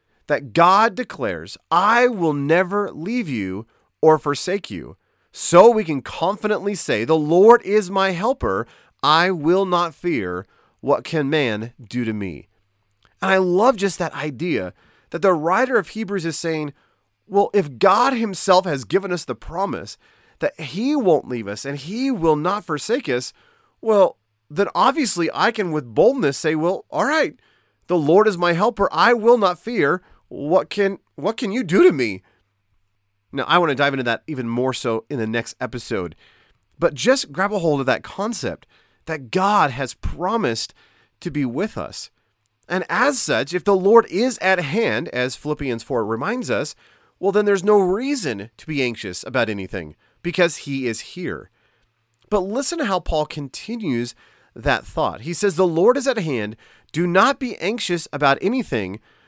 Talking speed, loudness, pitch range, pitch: 175 wpm, -20 LUFS, 125-200 Hz, 170 Hz